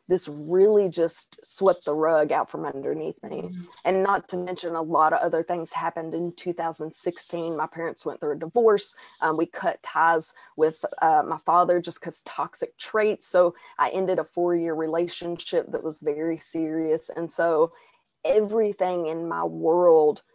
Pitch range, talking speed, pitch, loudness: 160-185 Hz, 165 wpm, 170 Hz, -25 LUFS